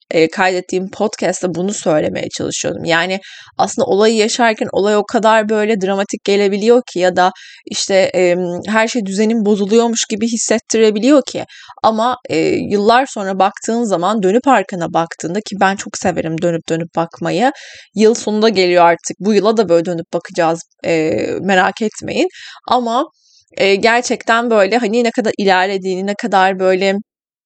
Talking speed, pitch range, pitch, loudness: 150 wpm, 185-230 Hz, 205 Hz, -15 LUFS